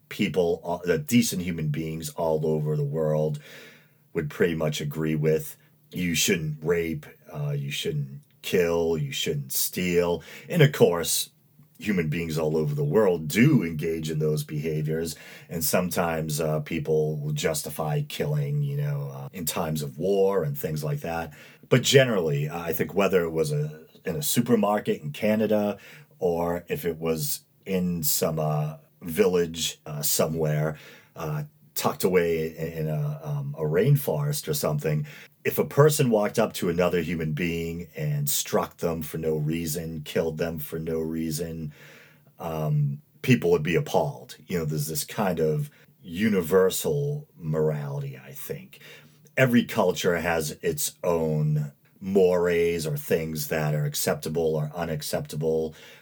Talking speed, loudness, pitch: 150 wpm, -26 LUFS, 85 Hz